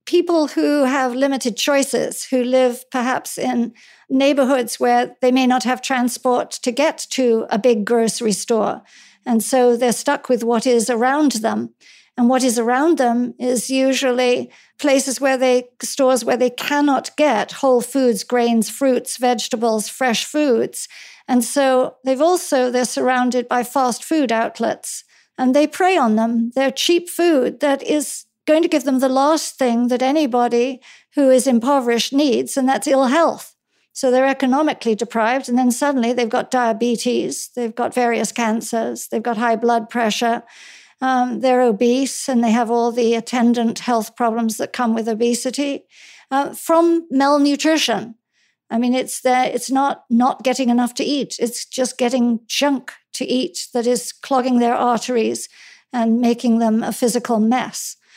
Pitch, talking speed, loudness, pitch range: 250 Hz, 160 wpm, -18 LUFS, 235-270 Hz